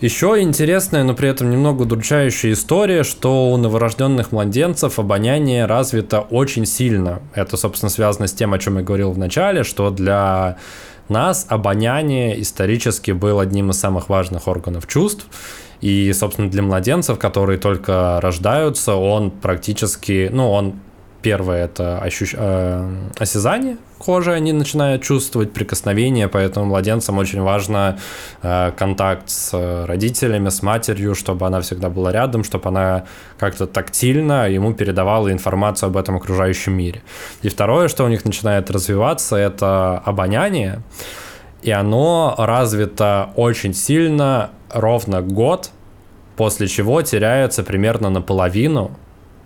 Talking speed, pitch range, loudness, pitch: 130 wpm, 95-120 Hz, -17 LUFS, 105 Hz